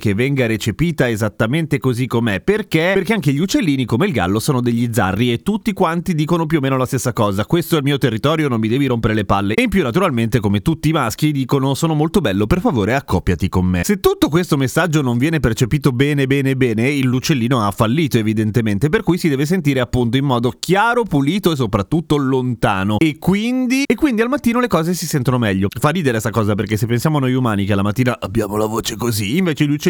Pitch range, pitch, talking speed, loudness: 115-165 Hz, 135 Hz, 230 wpm, -17 LUFS